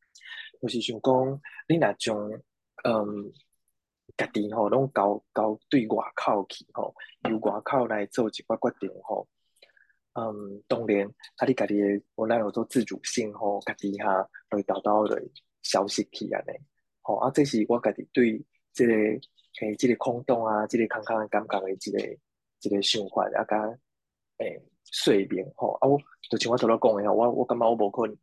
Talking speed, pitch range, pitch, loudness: 240 characters per minute, 105-120 Hz, 110 Hz, -27 LUFS